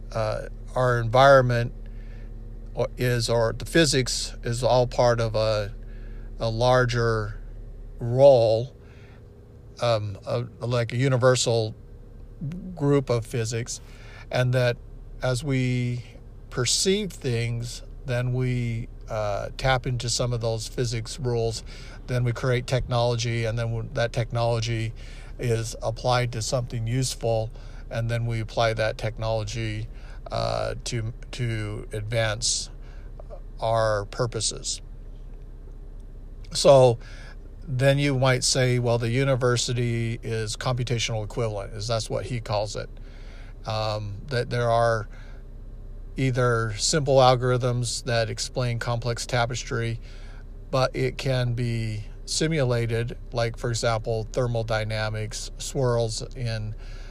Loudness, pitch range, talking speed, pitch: -25 LUFS, 110-125 Hz, 110 wpm, 115 Hz